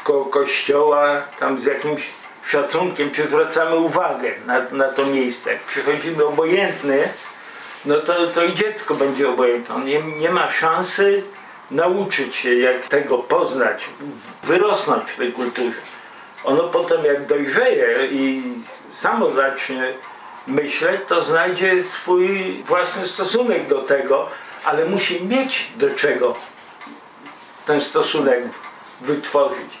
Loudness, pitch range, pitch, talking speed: -19 LUFS, 140-200 Hz, 165 Hz, 120 wpm